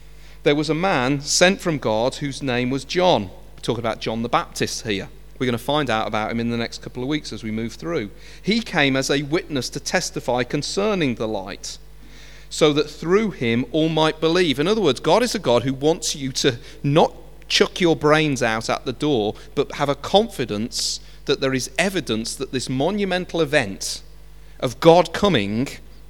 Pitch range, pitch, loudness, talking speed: 130-165 Hz, 145 Hz, -21 LUFS, 200 wpm